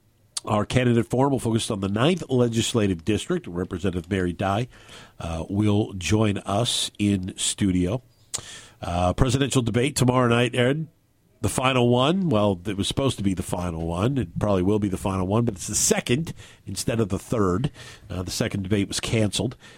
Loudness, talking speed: -24 LUFS, 175 wpm